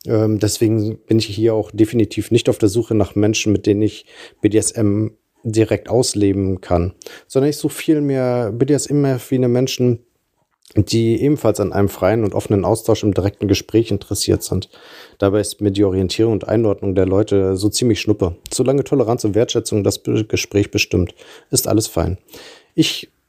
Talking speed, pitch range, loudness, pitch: 160 wpm, 100-115 Hz, -17 LUFS, 110 Hz